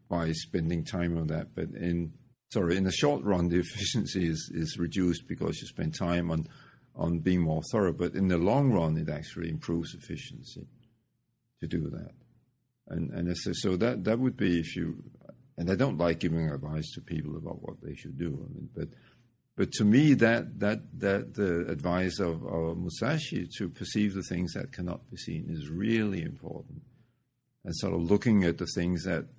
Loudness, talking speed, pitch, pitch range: -30 LUFS, 195 wpm, 90 Hz, 85-110 Hz